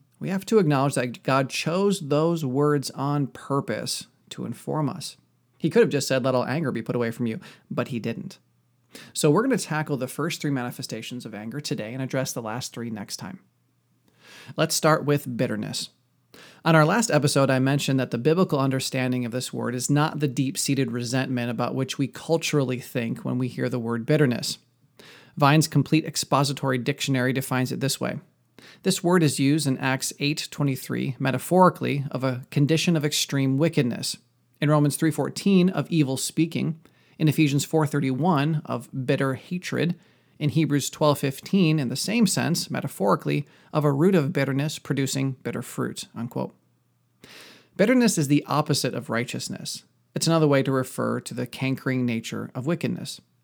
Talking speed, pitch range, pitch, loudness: 170 wpm, 130-155 Hz, 140 Hz, -24 LUFS